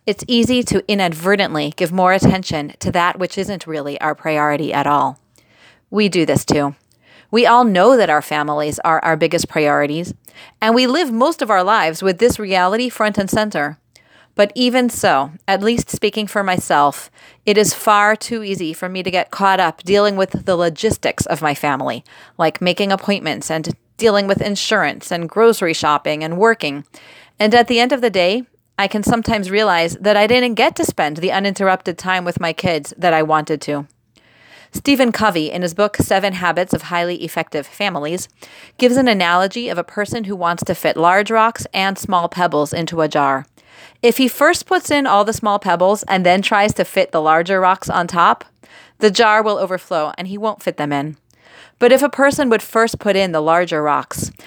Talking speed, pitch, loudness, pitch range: 195 wpm, 185 Hz, -16 LUFS, 160-215 Hz